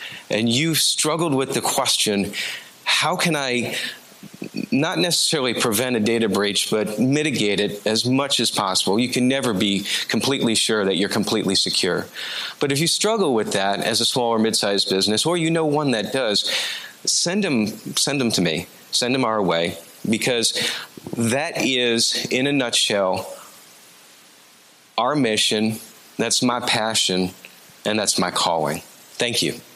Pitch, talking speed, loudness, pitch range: 115 Hz, 155 wpm, -20 LUFS, 100-135 Hz